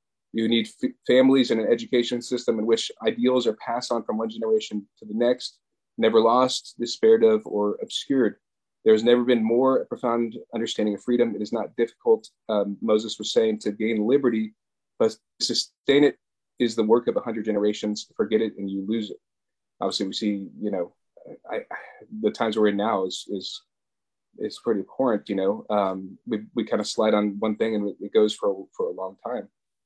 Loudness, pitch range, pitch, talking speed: -24 LUFS, 105-125 Hz, 115 Hz, 205 wpm